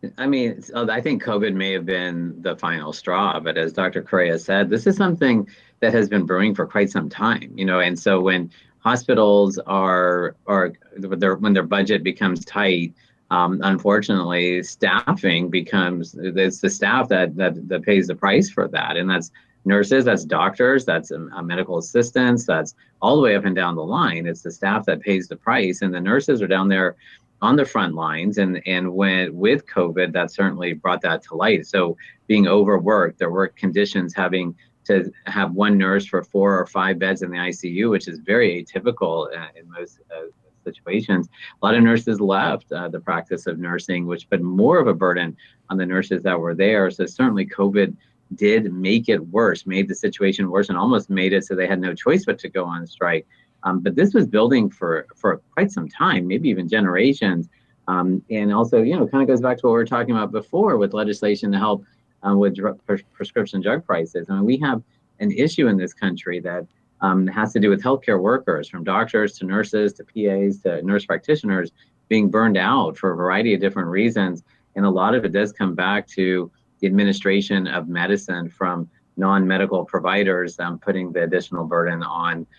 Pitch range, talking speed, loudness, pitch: 90-100 Hz, 195 wpm, -20 LUFS, 95 Hz